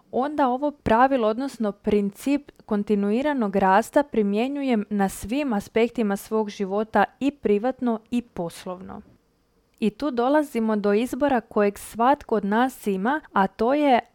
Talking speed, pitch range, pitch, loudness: 125 wpm, 205-265 Hz, 225 Hz, -23 LUFS